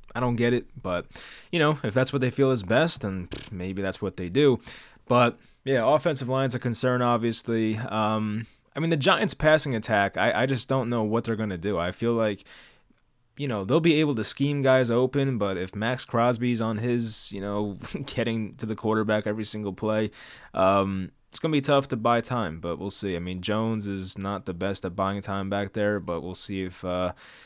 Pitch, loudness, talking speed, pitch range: 110 Hz, -26 LUFS, 215 wpm, 100-125 Hz